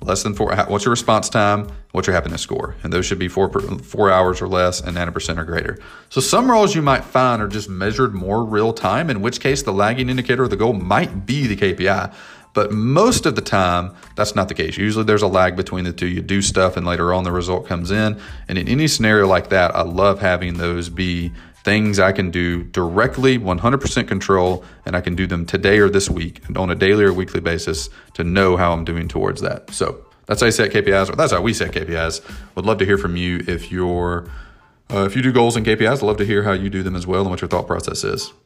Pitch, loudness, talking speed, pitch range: 95 Hz, -18 LUFS, 250 wpm, 90-105 Hz